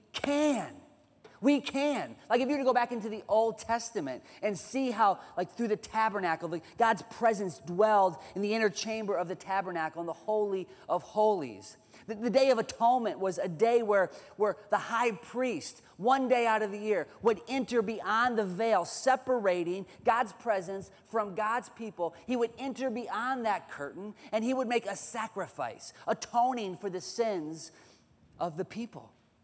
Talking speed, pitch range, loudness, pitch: 175 wpm, 195-240 Hz, -31 LUFS, 220 Hz